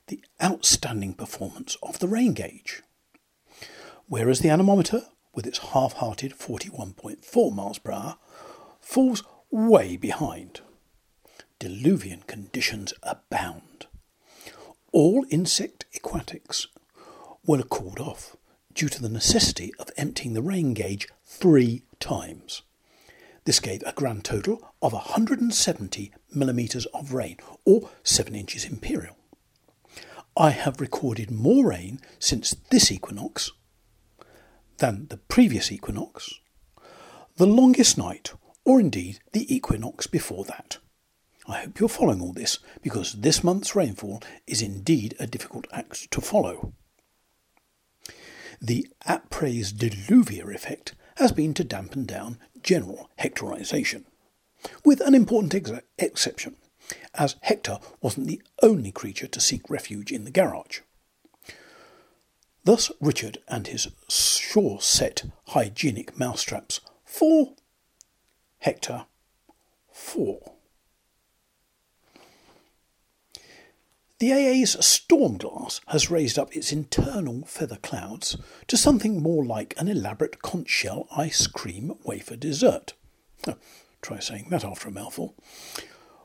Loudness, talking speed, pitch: -24 LUFS, 110 wpm, 155 Hz